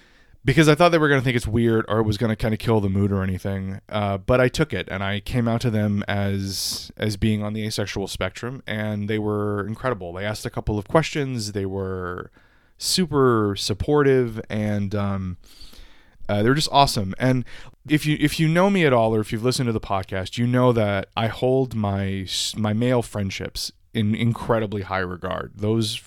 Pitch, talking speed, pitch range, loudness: 110 Hz, 205 wpm, 100-125 Hz, -22 LUFS